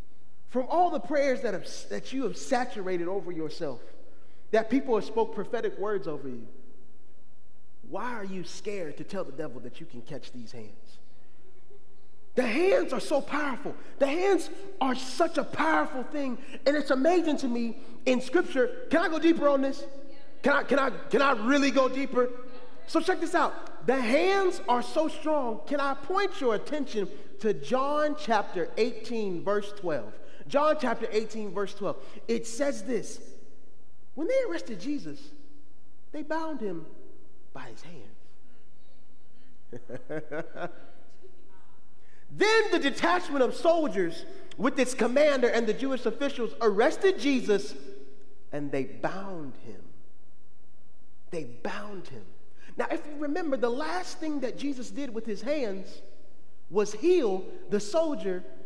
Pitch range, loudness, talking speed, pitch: 205-295 Hz, -29 LUFS, 145 wpm, 255 Hz